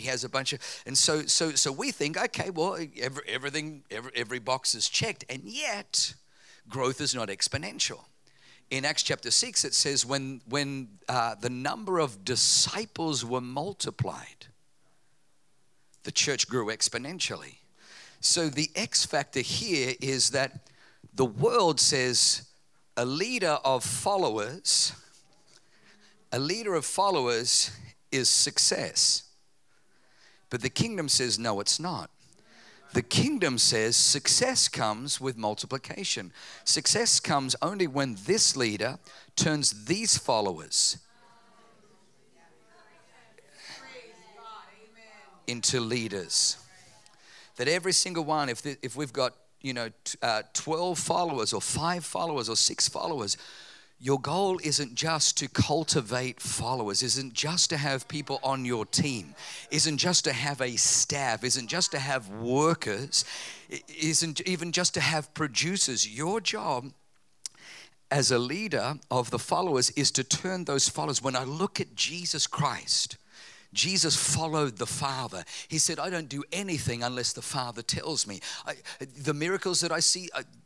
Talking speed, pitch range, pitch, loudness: 135 wpm, 125-165 Hz, 140 Hz, -27 LUFS